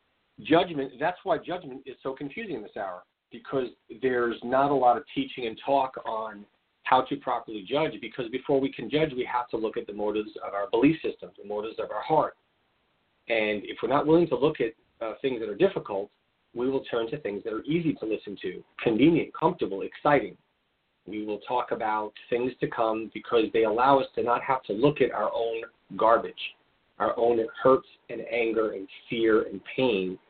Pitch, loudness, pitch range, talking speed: 120 Hz, -27 LUFS, 110-140 Hz, 200 wpm